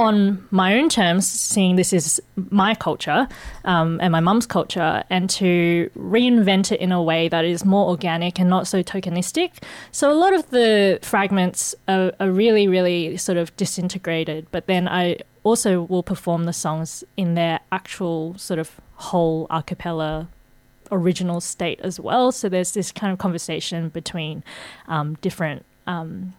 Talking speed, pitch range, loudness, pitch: 165 wpm, 170-195 Hz, -20 LUFS, 180 Hz